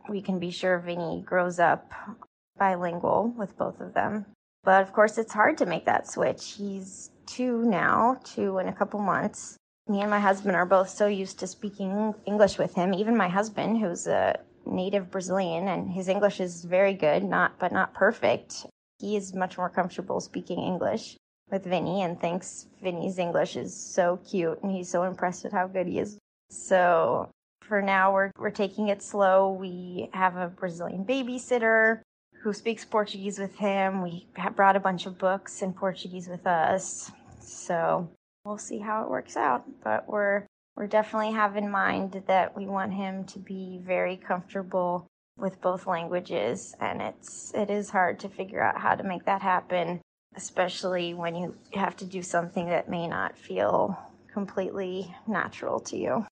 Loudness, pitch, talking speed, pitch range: -28 LUFS, 195 Hz, 175 wpm, 185-205 Hz